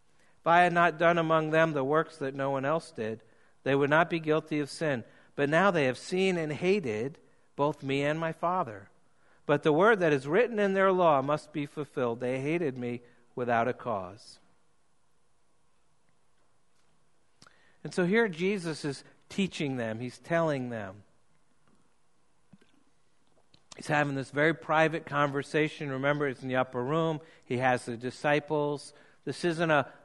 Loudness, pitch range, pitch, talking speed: -29 LUFS, 135-165 Hz, 150 Hz, 160 wpm